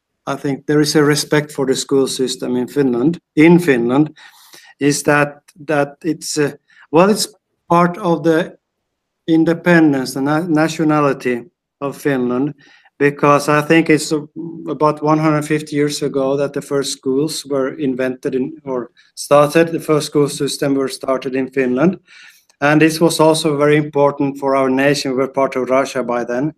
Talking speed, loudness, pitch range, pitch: 165 wpm, -16 LUFS, 135-155 Hz, 145 Hz